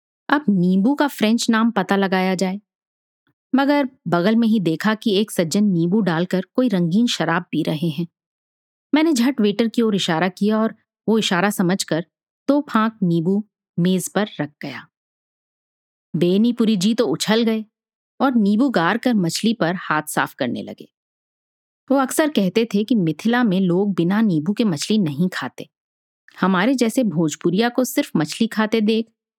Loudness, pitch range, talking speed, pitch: -19 LUFS, 180-230 Hz, 165 wpm, 210 Hz